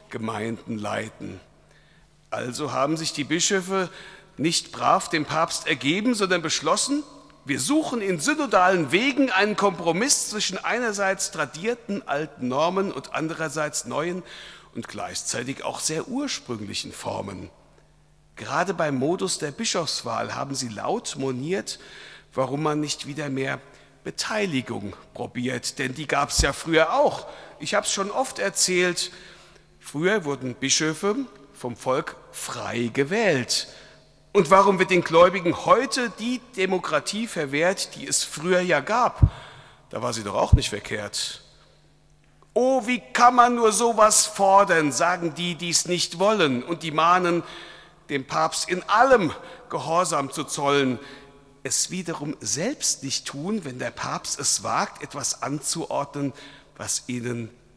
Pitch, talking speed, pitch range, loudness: 170 Hz, 135 wpm, 140-195 Hz, -23 LUFS